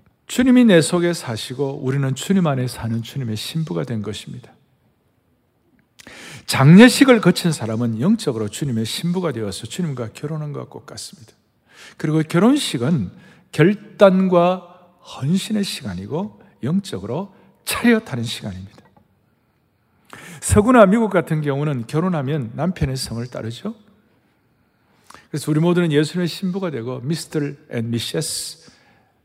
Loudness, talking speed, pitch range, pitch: -19 LUFS, 285 characters per minute, 120-185 Hz, 155 Hz